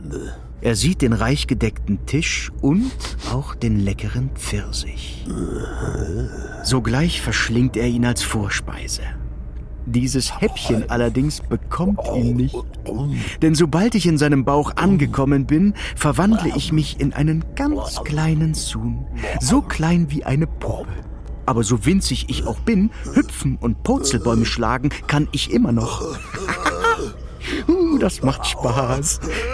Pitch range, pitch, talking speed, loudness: 115-160 Hz, 130 Hz, 125 wpm, -20 LUFS